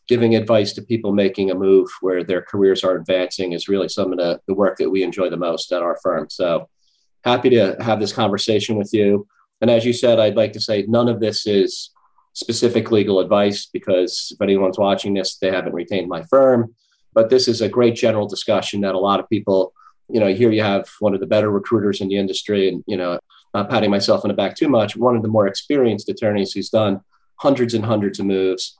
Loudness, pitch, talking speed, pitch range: -18 LUFS, 100 Hz, 225 wpm, 95-115 Hz